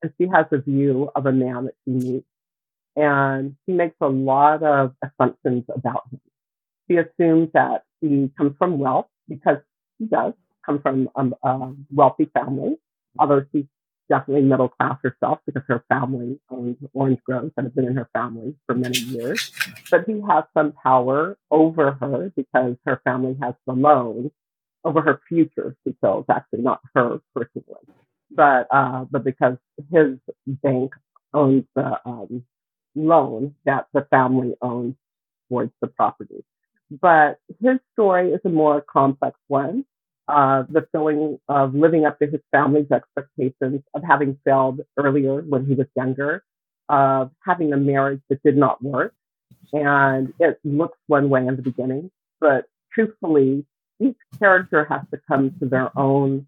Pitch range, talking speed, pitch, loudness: 130-155 Hz, 155 wpm, 140 Hz, -20 LUFS